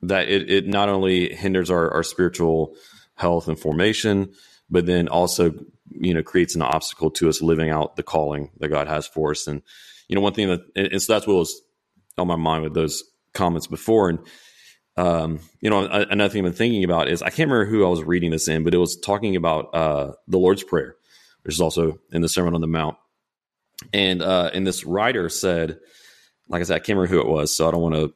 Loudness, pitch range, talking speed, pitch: -21 LUFS, 80-95 Hz, 230 wpm, 85 Hz